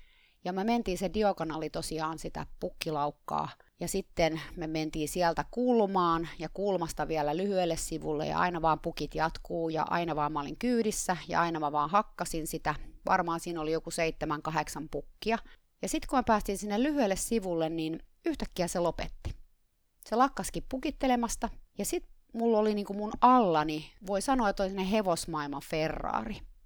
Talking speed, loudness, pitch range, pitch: 160 wpm, -31 LUFS, 155-210 Hz, 170 Hz